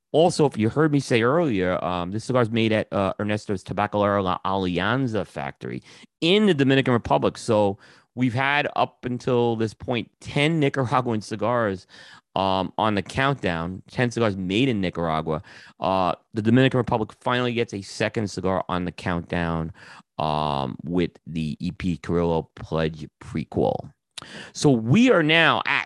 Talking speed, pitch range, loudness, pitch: 155 wpm, 90-125 Hz, -23 LUFS, 105 Hz